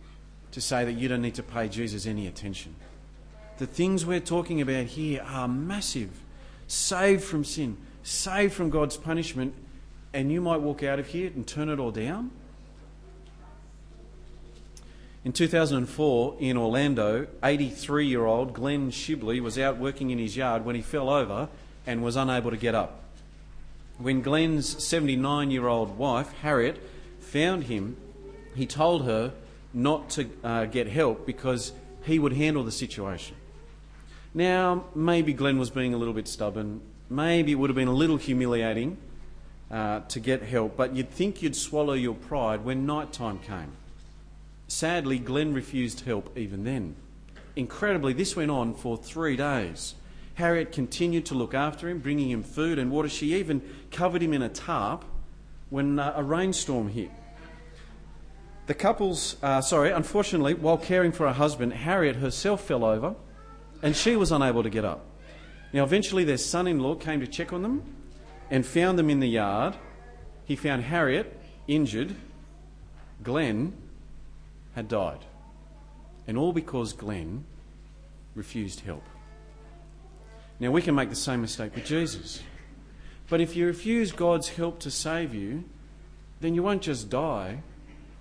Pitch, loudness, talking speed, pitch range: 140 Hz, -28 LUFS, 155 wpm, 120-160 Hz